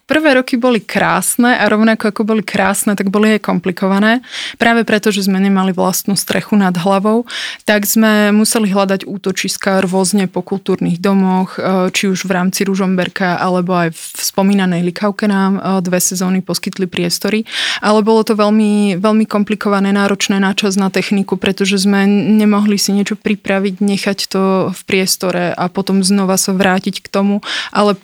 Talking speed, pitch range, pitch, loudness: 160 wpm, 190-210 Hz, 200 Hz, -13 LUFS